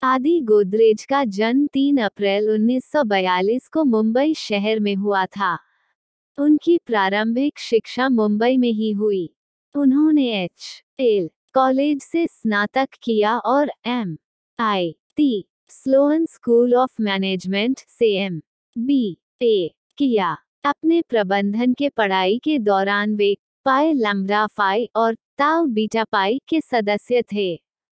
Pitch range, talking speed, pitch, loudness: 205-275 Hz, 115 wpm, 230 Hz, -20 LUFS